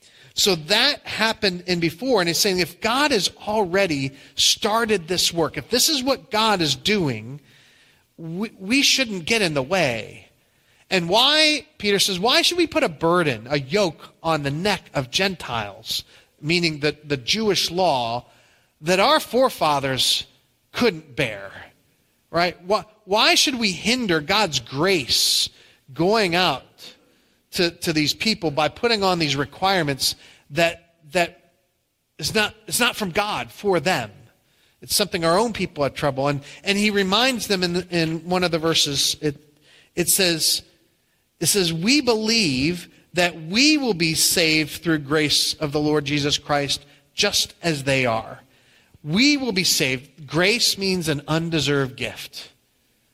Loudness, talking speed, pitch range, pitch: -20 LUFS, 155 wpm, 145-205 Hz, 170 Hz